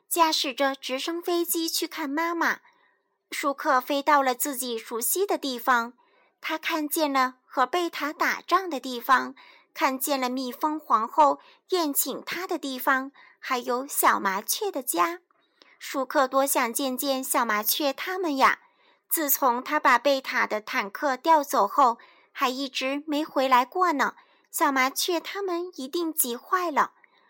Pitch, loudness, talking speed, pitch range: 295 Hz, -25 LUFS, 215 characters per minute, 265-350 Hz